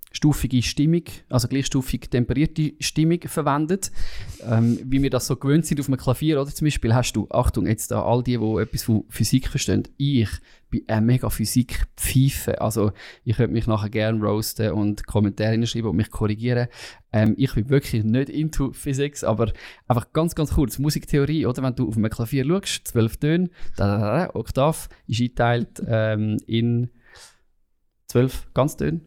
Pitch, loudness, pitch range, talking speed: 125 Hz, -23 LUFS, 110-140 Hz, 165 wpm